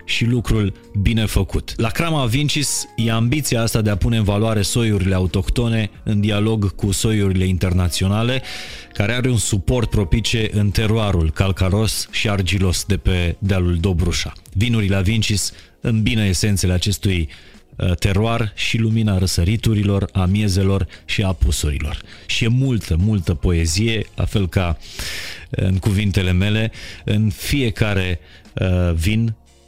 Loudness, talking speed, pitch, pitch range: -19 LUFS, 135 wpm, 100 Hz, 95-110 Hz